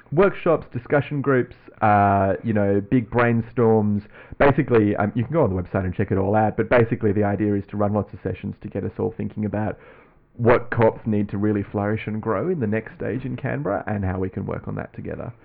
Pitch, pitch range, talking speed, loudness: 105 Hz, 100-115 Hz, 230 wpm, -22 LUFS